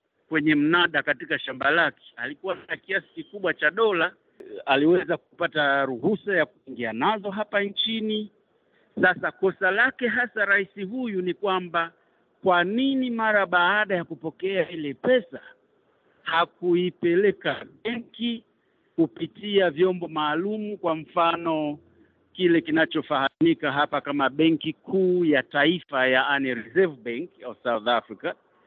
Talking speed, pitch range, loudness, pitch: 115 wpm, 155-215 Hz, -24 LUFS, 180 Hz